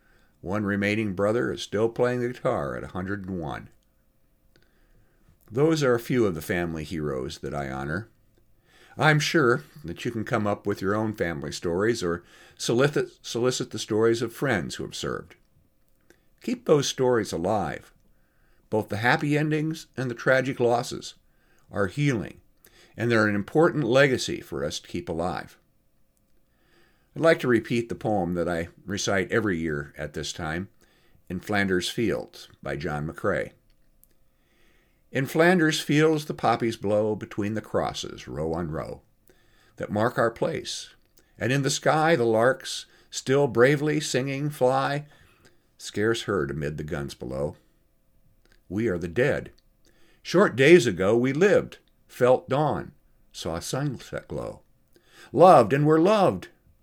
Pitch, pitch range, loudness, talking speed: 115 Hz, 95-135 Hz, -25 LUFS, 145 wpm